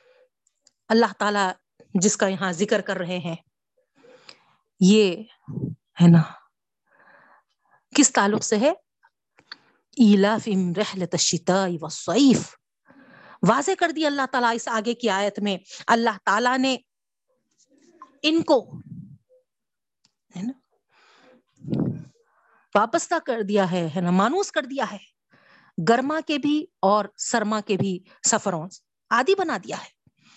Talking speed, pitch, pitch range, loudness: 105 wpm, 220 Hz, 190-280 Hz, -22 LUFS